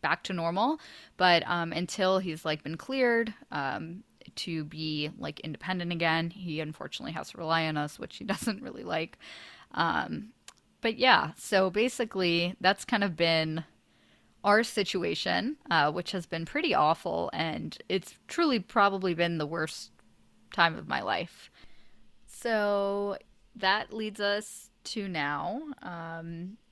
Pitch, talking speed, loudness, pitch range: 185 Hz, 140 wpm, -30 LUFS, 165-220 Hz